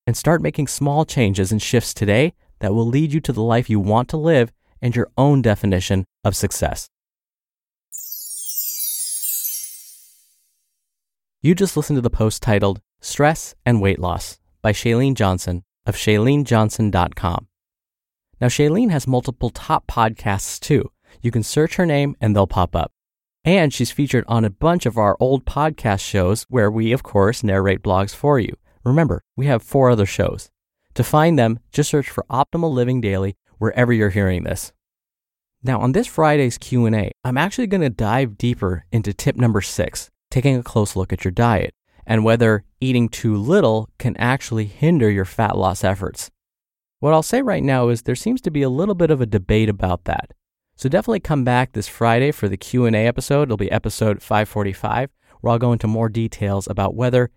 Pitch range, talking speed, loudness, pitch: 100-135 Hz, 175 wpm, -19 LUFS, 115 Hz